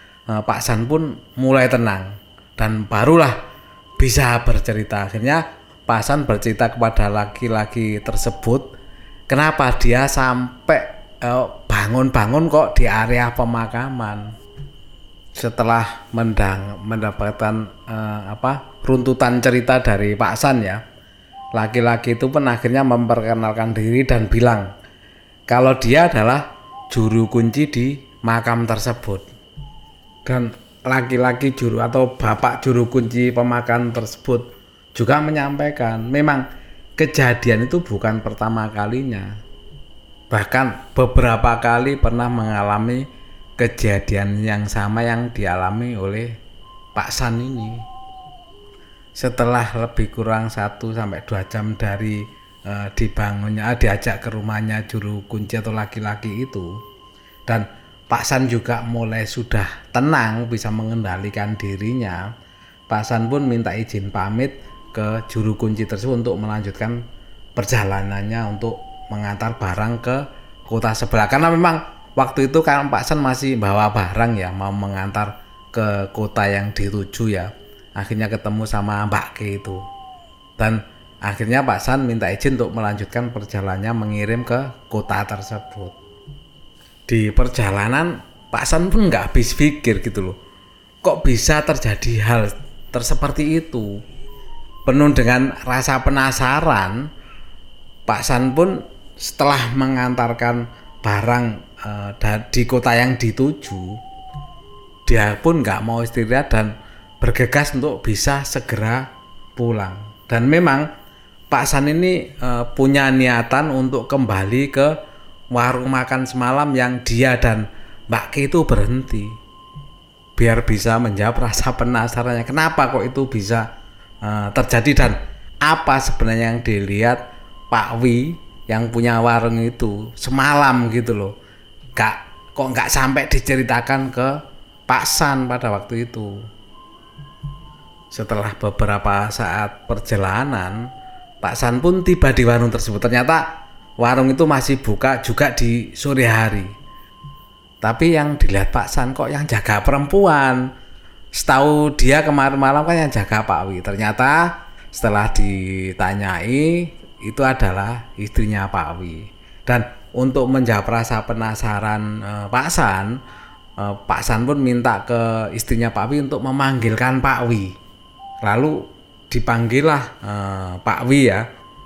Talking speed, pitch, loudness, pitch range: 120 wpm, 115 Hz, -18 LUFS, 105-130 Hz